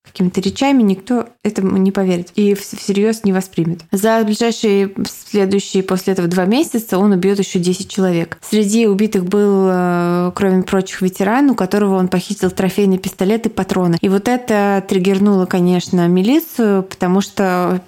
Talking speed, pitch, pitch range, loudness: 150 wpm, 195 Hz, 185-210 Hz, -15 LUFS